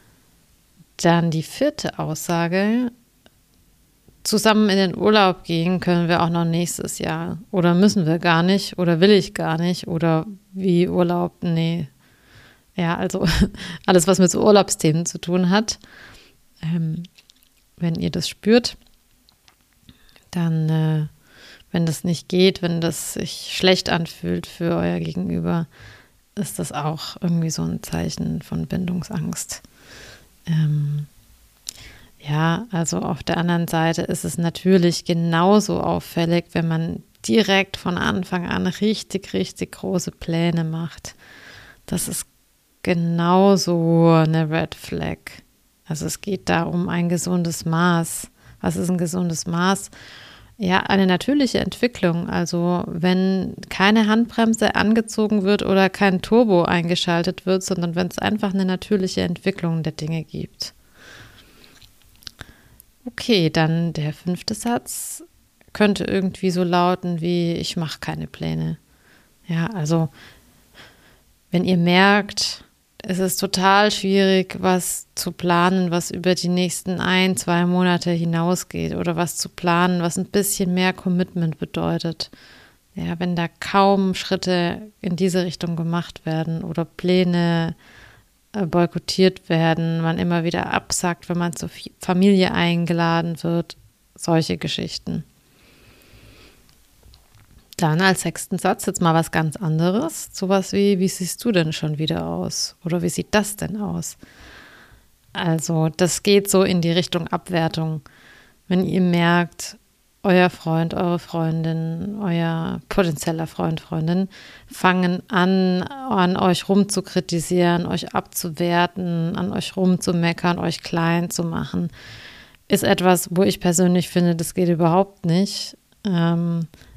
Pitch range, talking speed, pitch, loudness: 165-190 Hz, 130 wpm, 175 Hz, -20 LUFS